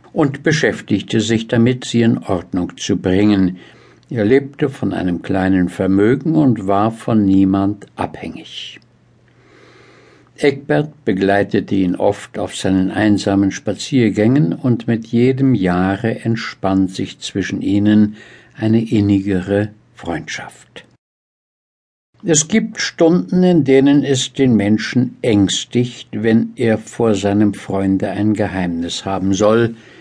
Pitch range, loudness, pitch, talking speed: 95-125 Hz, -16 LUFS, 105 Hz, 115 wpm